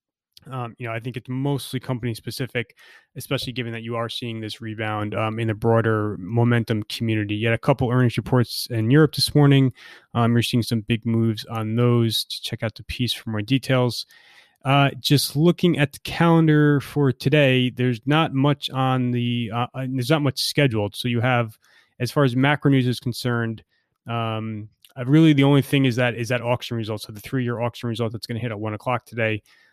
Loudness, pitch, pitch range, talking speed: -22 LUFS, 120 Hz, 115-135 Hz, 205 wpm